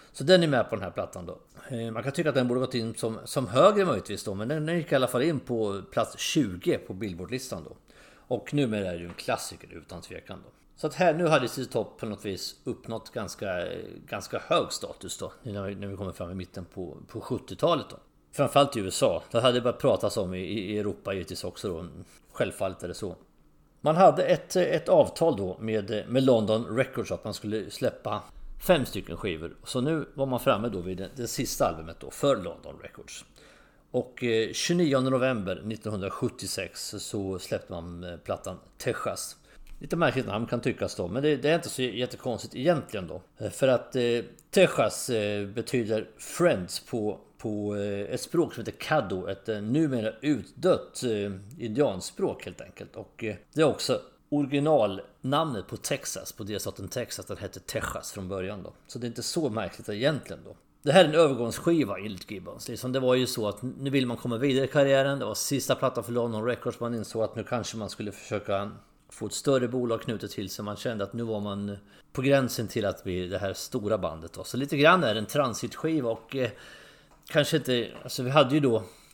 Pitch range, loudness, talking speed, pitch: 100-135 Hz, -28 LUFS, 195 wpm, 115 Hz